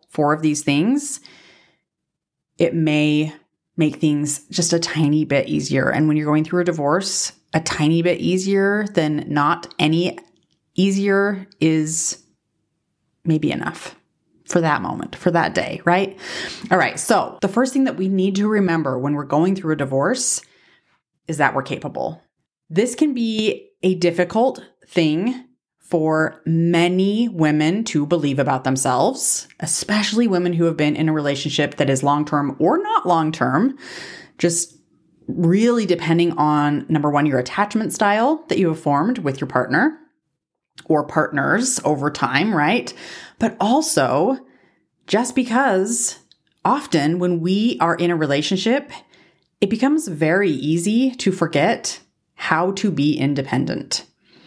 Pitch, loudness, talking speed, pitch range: 170 Hz, -19 LUFS, 145 wpm, 150-200 Hz